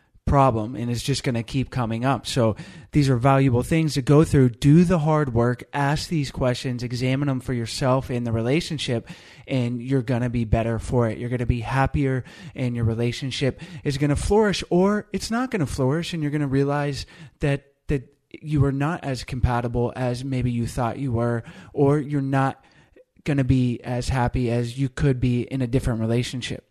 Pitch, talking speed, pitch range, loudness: 135 Hz, 205 wpm, 120-145 Hz, -23 LUFS